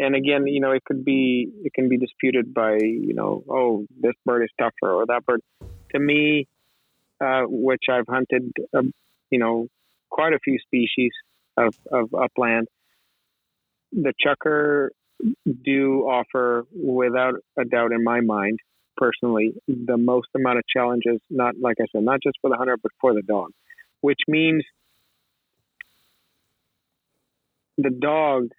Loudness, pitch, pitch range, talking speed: -22 LUFS, 125 Hz, 120-135 Hz, 150 wpm